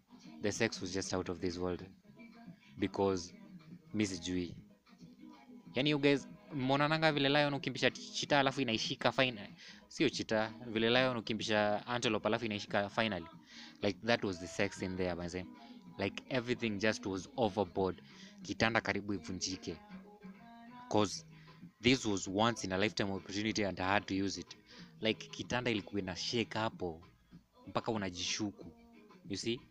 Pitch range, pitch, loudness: 95-135 Hz, 110 Hz, -35 LUFS